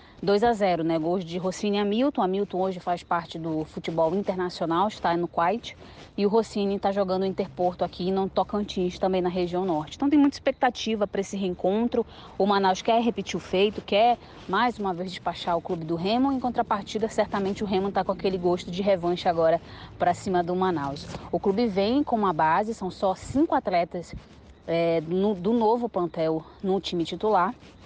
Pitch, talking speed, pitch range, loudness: 190 Hz, 185 wpm, 180-210 Hz, -26 LUFS